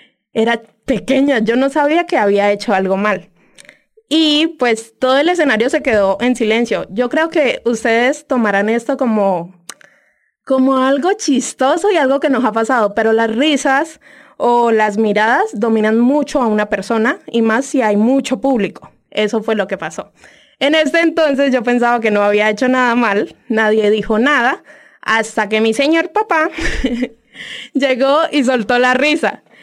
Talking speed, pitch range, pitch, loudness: 165 wpm, 220-280 Hz, 245 Hz, -14 LUFS